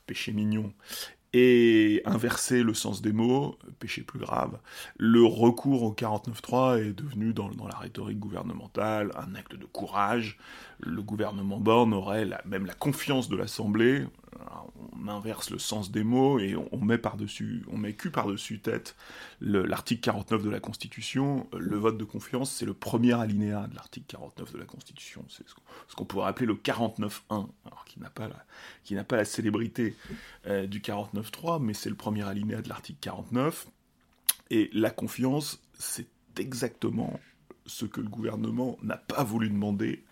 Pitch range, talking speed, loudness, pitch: 105-120 Hz, 170 wpm, -29 LUFS, 110 Hz